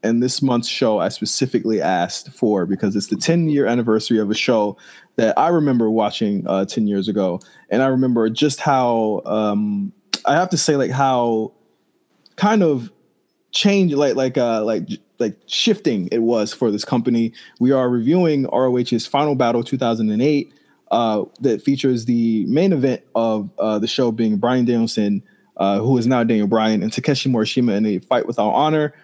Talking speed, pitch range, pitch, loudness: 180 wpm, 110-135 Hz, 120 Hz, -19 LUFS